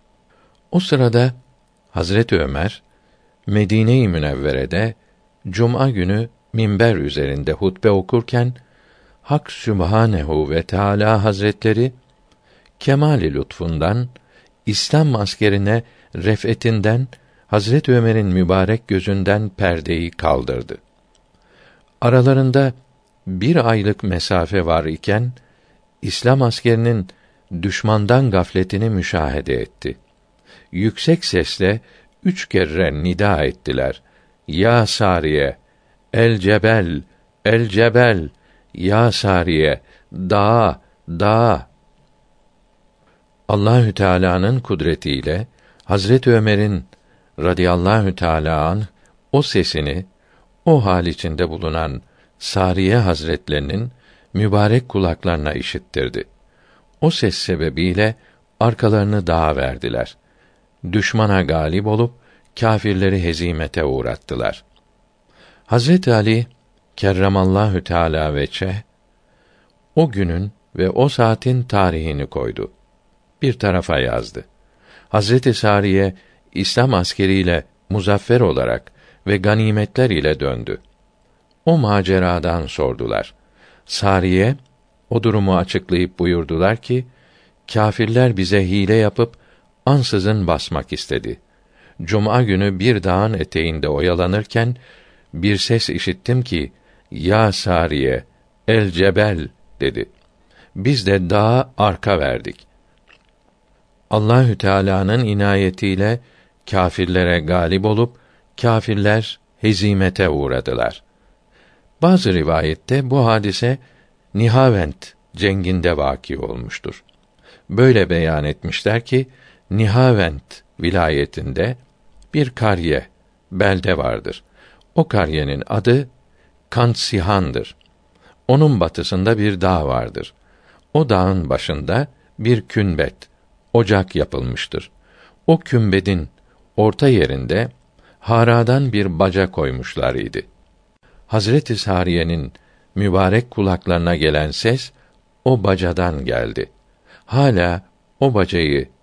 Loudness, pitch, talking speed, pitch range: -17 LUFS, 100 Hz, 85 wpm, 85-115 Hz